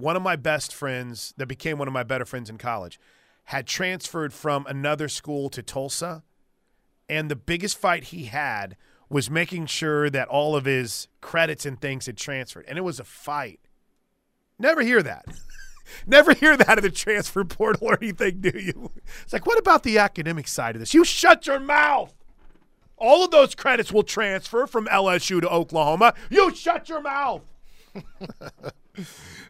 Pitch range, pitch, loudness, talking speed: 140-220 Hz, 165 Hz, -22 LUFS, 175 wpm